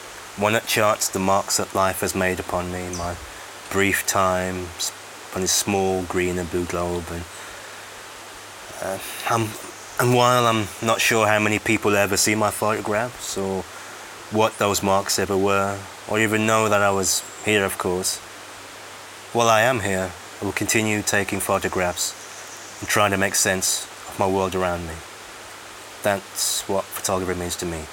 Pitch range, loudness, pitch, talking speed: 90-105 Hz, -21 LUFS, 95 Hz, 165 wpm